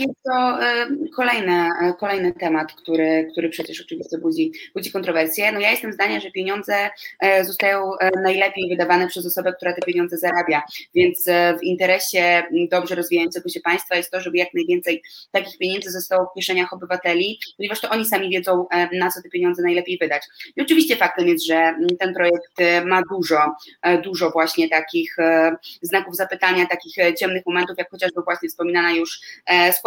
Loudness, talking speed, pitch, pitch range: -20 LUFS, 155 wpm, 180 Hz, 175-195 Hz